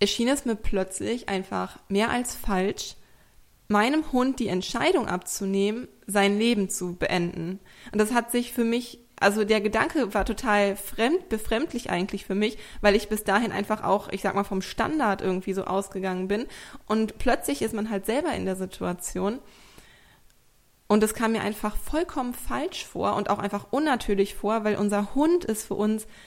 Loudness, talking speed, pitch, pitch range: -26 LUFS, 175 wpm, 210 Hz, 195-235 Hz